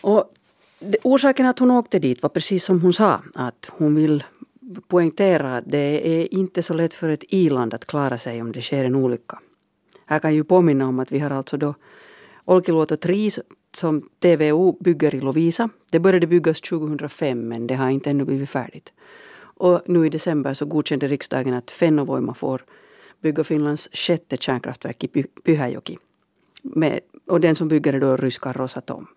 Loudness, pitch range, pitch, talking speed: -20 LUFS, 135-180 Hz, 155 Hz, 175 wpm